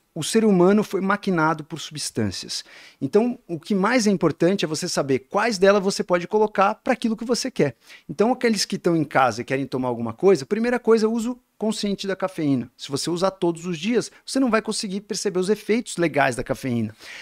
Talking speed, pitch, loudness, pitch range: 210 wpm, 190 Hz, -22 LUFS, 160-215 Hz